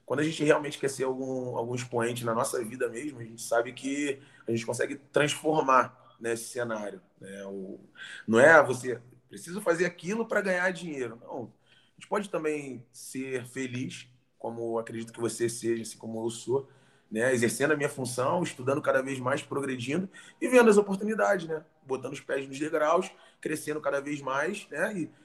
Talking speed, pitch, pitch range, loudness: 185 wpm, 130 Hz, 120-155 Hz, -29 LUFS